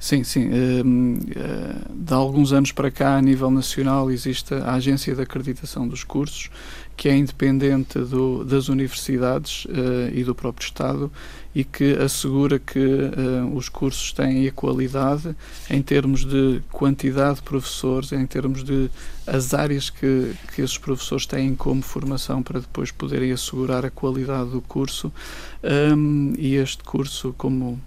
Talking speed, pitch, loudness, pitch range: 155 wpm, 135 Hz, -22 LUFS, 130-140 Hz